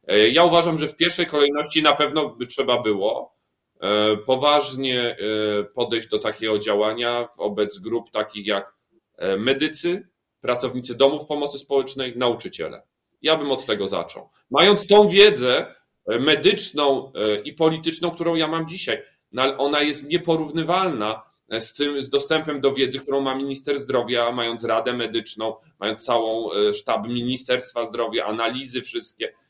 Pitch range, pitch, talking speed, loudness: 120-160 Hz, 135 Hz, 130 wpm, -21 LUFS